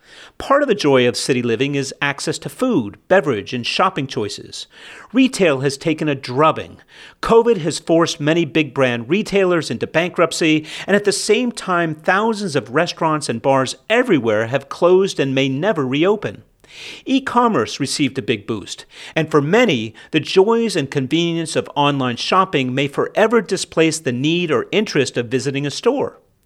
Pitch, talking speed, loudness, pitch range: 160 Hz, 165 wpm, -18 LUFS, 140-195 Hz